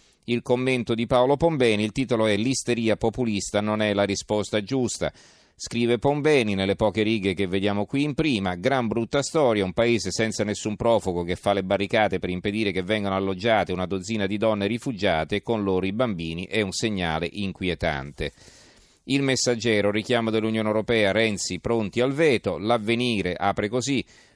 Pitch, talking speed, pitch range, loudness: 110 Hz, 165 wpm, 100-120 Hz, -24 LUFS